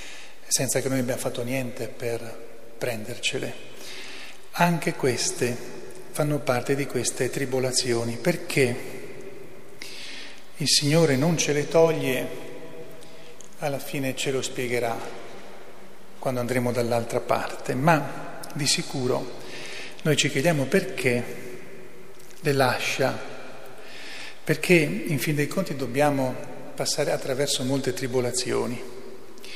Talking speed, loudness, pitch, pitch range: 100 wpm, -25 LUFS, 135 Hz, 125-150 Hz